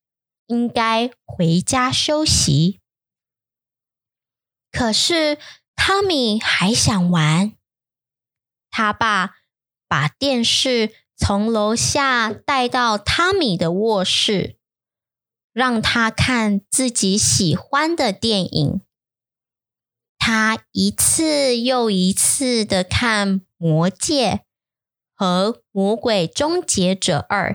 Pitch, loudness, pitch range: 205 Hz, -18 LUFS, 165-245 Hz